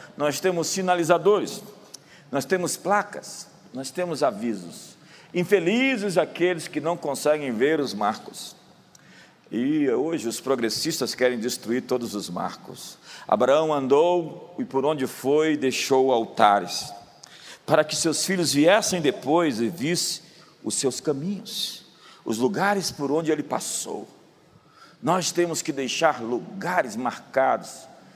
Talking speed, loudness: 120 wpm, -24 LUFS